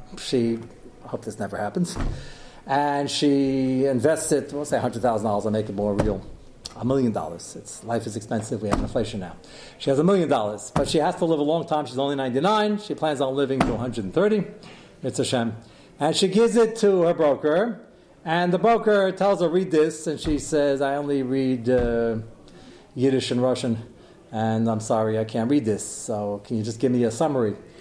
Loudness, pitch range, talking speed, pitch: -23 LUFS, 115-155 Hz, 200 wpm, 135 Hz